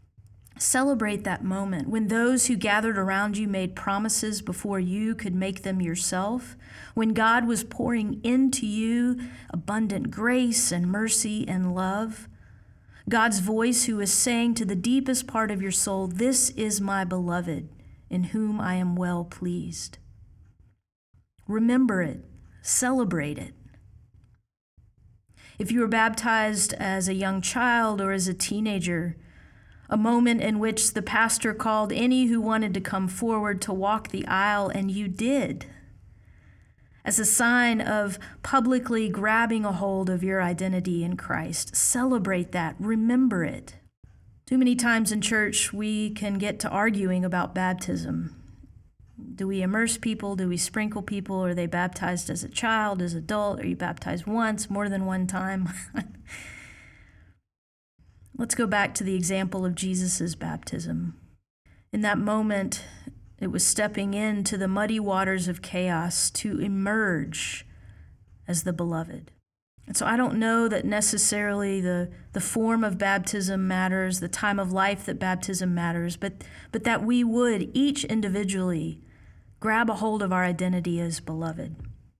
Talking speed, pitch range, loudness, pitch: 145 wpm, 175-220 Hz, -26 LUFS, 195 Hz